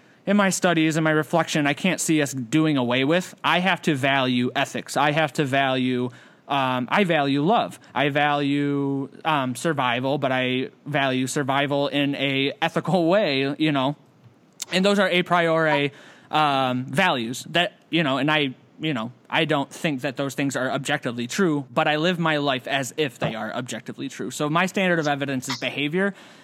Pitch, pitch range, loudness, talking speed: 145 Hz, 135-165 Hz, -22 LUFS, 185 wpm